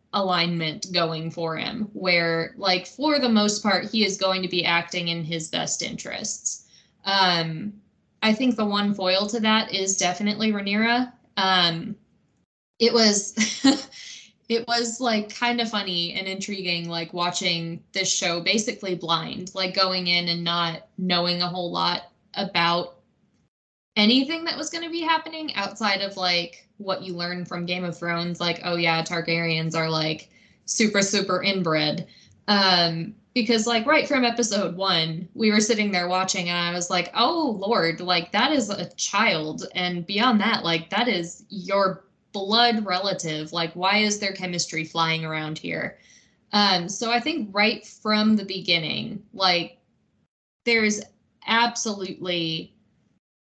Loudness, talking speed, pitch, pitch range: -23 LUFS, 150 wpm, 190 Hz, 175-215 Hz